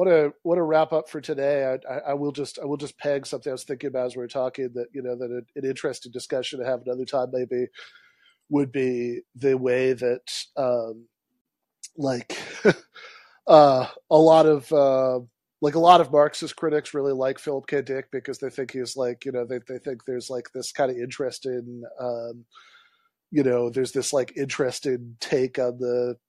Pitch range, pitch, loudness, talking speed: 125-145 Hz, 130 Hz, -24 LUFS, 205 wpm